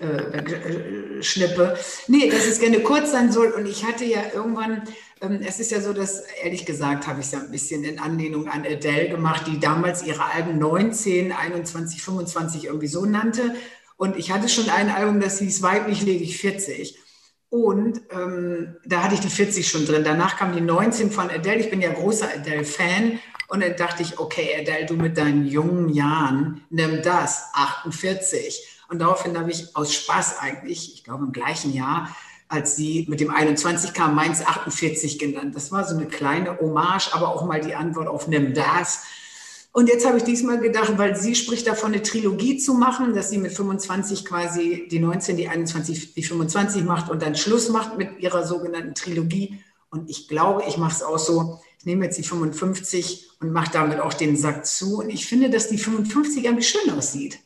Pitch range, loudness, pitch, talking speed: 160-210 Hz, -22 LUFS, 175 Hz, 195 wpm